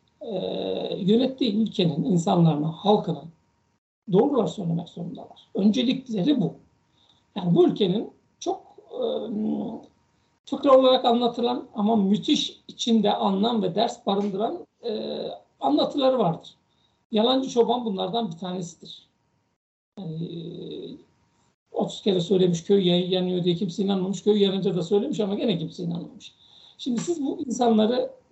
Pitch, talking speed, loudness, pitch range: 205 Hz, 120 wpm, -24 LUFS, 180-240 Hz